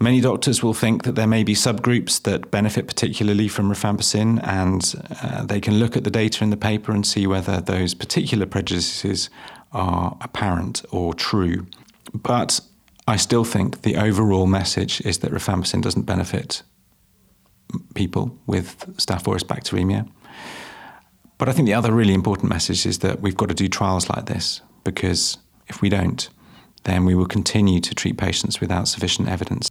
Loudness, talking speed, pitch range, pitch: -21 LUFS, 165 wpm, 95-110 Hz, 100 Hz